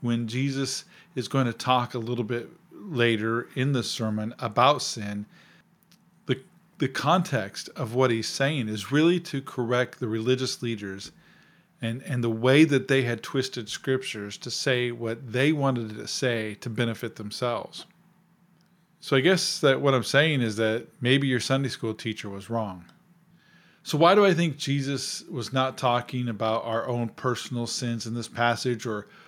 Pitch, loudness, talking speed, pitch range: 125 Hz, -26 LUFS, 170 wpm, 115-145 Hz